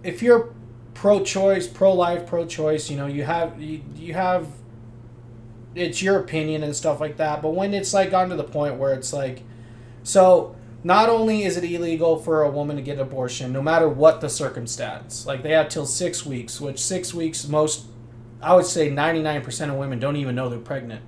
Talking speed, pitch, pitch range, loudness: 205 wpm, 150 Hz, 125-175 Hz, -22 LUFS